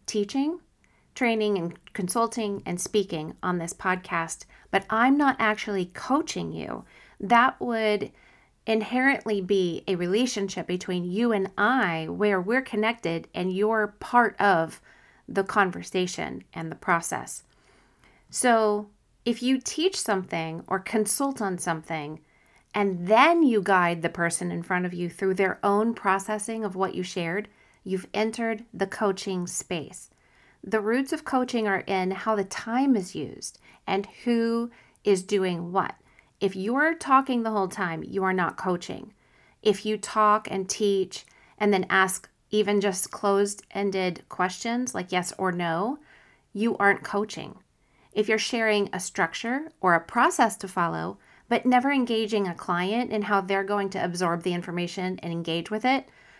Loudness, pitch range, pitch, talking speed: -26 LUFS, 185-225 Hz, 200 Hz, 150 wpm